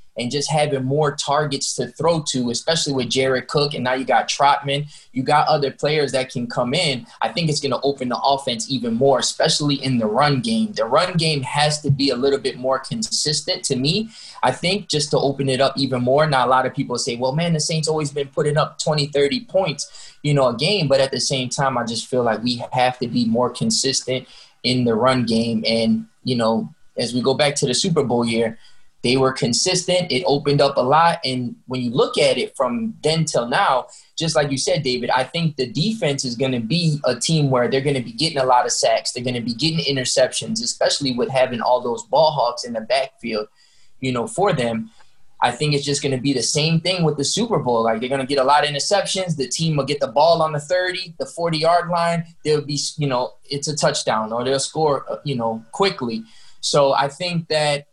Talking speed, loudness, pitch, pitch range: 240 wpm, -20 LUFS, 140 Hz, 125-155 Hz